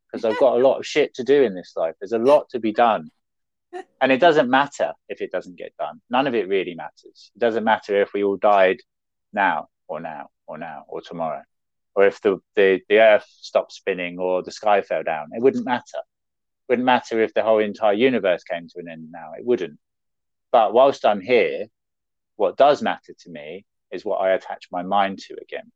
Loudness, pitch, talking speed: -20 LUFS, 125 Hz, 220 wpm